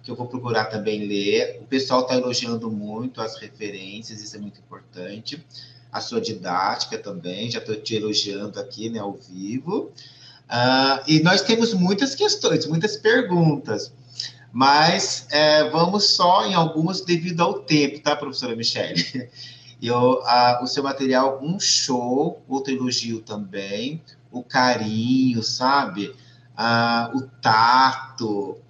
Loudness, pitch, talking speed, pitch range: -21 LUFS, 125 Hz, 135 wpm, 115-145 Hz